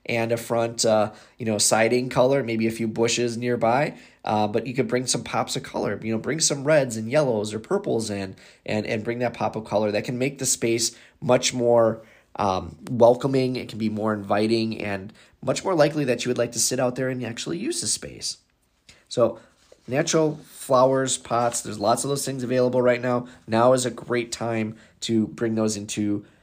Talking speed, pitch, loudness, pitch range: 205 wpm, 115 Hz, -23 LUFS, 110-125 Hz